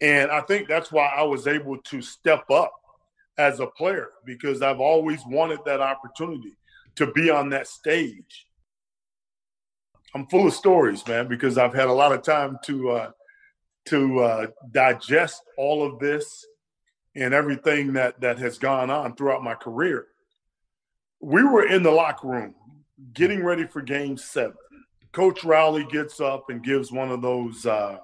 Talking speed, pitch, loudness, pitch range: 165 wpm, 140 Hz, -23 LUFS, 130-155 Hz